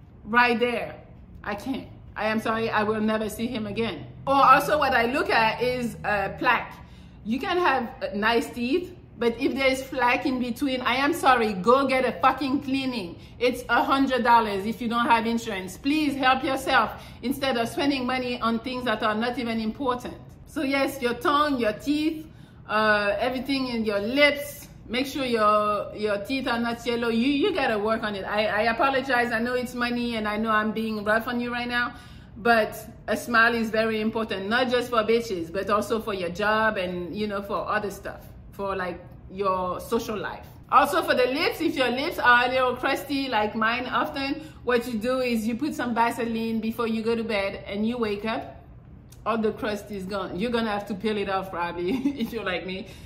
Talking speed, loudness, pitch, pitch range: 205 wpm, -25 LUFS, 235 Hz, 215-255 Hz